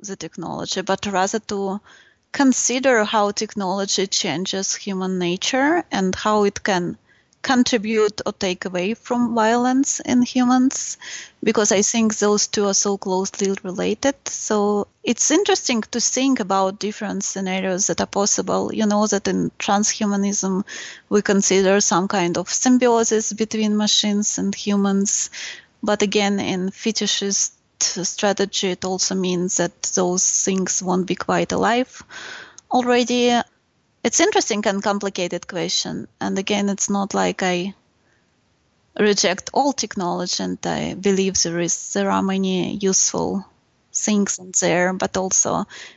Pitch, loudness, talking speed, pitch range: 200 Hz, -20 LUFS, 135 wpm, 190-220 Hz